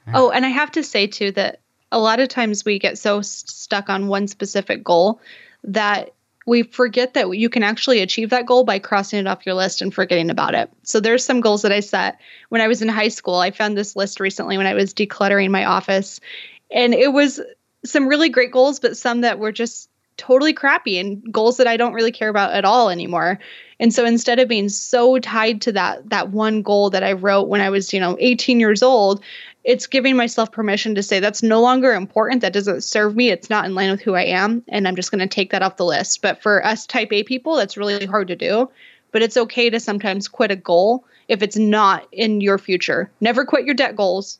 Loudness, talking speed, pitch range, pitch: -17 LUFS, 235 wpm, 200-240 Hz, 215 Hz